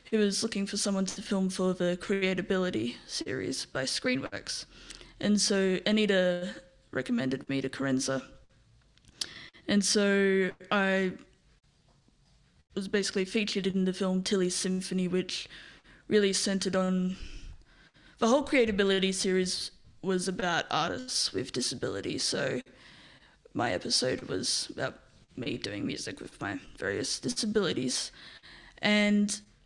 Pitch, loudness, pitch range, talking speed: 190 Hz, -30 LUFS, 185-205 Hz, 115 wpm